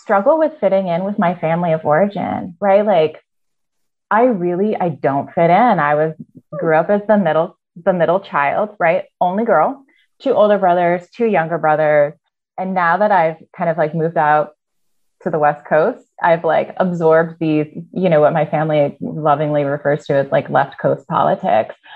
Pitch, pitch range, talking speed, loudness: 170 Hz, 155-200 Hz, 180 wpm, -16 LUFS